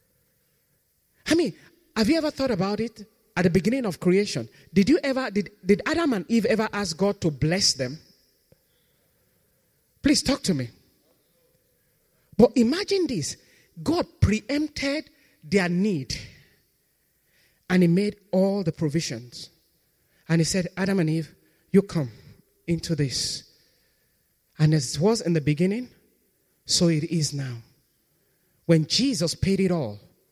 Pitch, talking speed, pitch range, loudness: 185 Hz, 140 wpm, 155-220 Hz, -24 LUFS